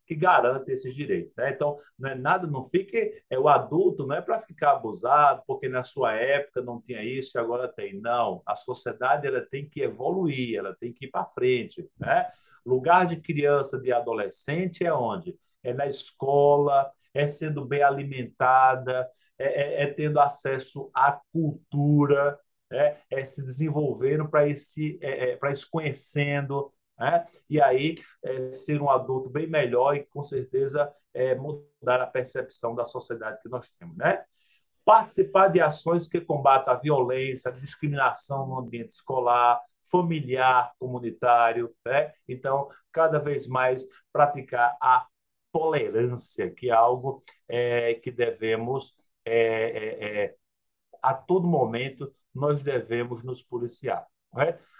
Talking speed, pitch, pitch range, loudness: 145 wpm, 140 Hz, 125-155 Hz, -26 LUFS